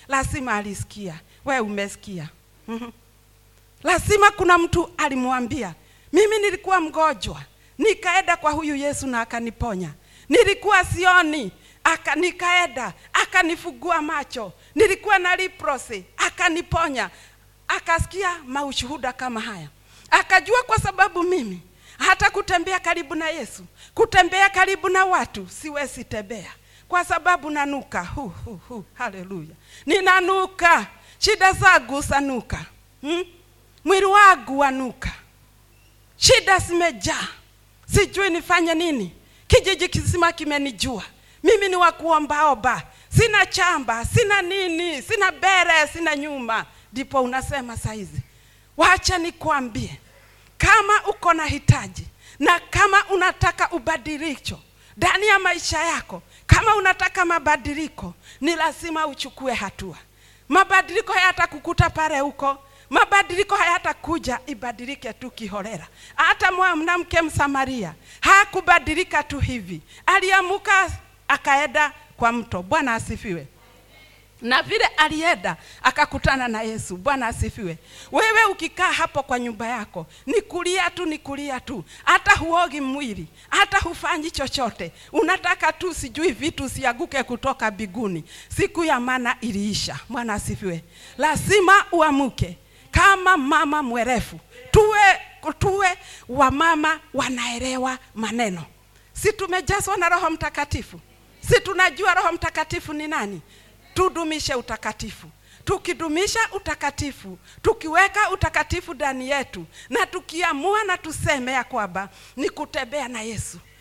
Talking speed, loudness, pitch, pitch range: 100 wpm, -20 LUFS, 315 Hz, 255-370 Hz